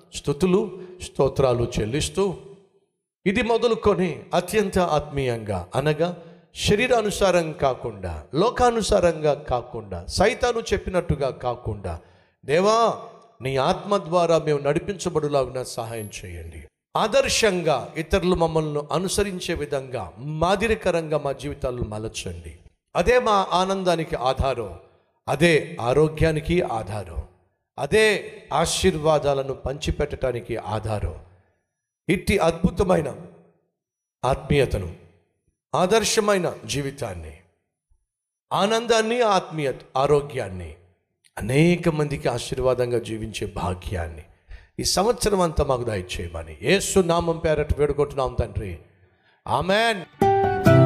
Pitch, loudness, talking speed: 145 Hz, -23 LUFS, 80 wpm